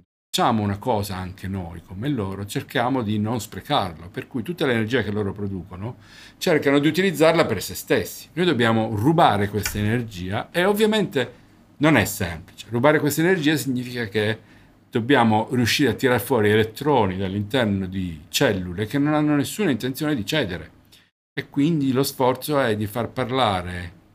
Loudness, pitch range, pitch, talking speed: -22 LUFS, 100-140 Hz, 115 Hz, 155 wpm